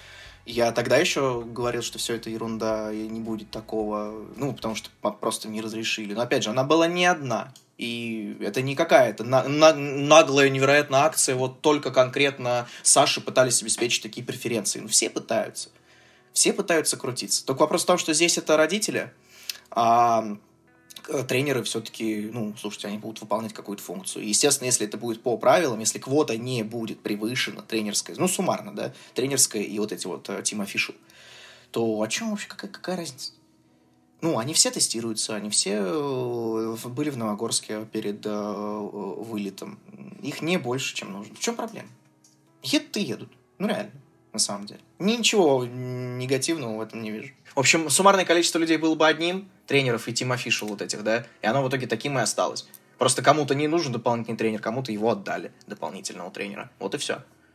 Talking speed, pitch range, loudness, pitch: 170 wpm, 110-145 Hz, -24 LUFS, 120 Hz